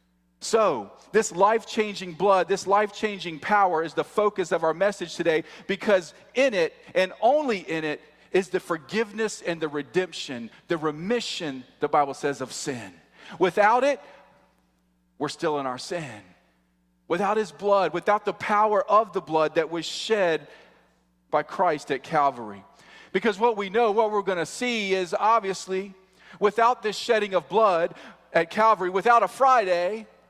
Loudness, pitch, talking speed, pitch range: -24 LUFS, 190 Hz, 155 wpm, 155-210 Hz